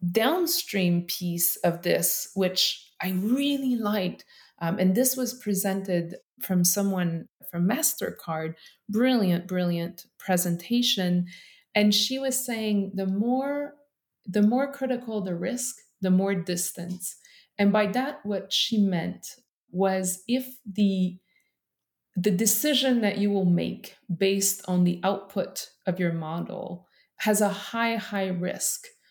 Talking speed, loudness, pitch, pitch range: 125 wpm, -26 LUFS, 195 Hz, 180-240 Hz